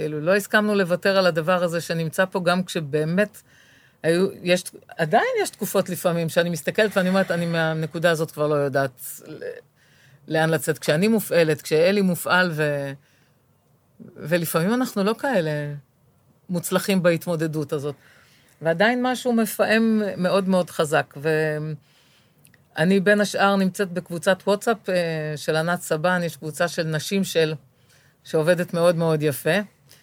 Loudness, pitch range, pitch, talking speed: -22 LUFS, 155-195 Hz, 175 Hz, 130 wpm